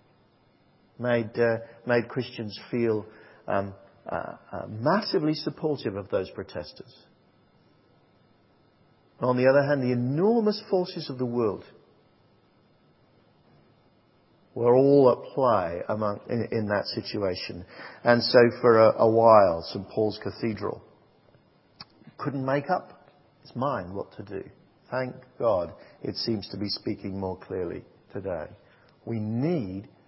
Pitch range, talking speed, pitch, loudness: 110-140 Hz, 125 wpm, 120 Hz, -26 LUFS